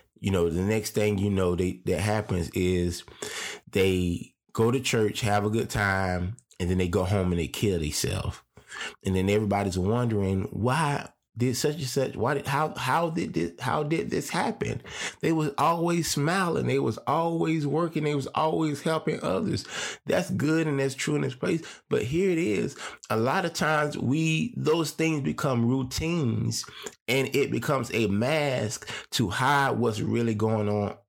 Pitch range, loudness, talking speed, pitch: 100-150 Hz, -27 LUFS, 180 wpm, 115 Hz